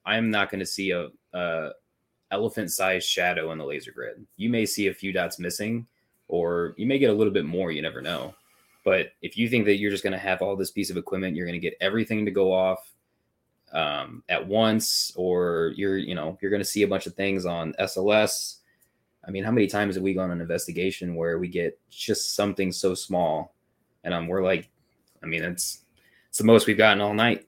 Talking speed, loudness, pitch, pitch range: 225 wpm, -25 LUFS, 95 Hz, 90-105 Hz